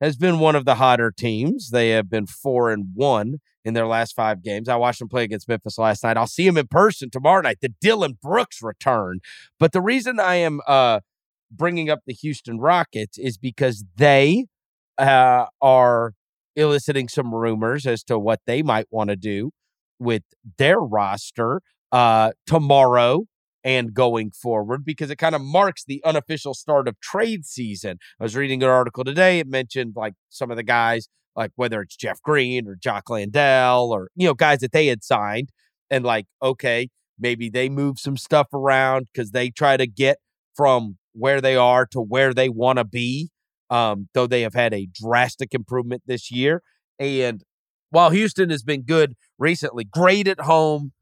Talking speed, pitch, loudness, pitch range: 185 wpm, 130 Hz, -20 LUFS, 115-145 Hz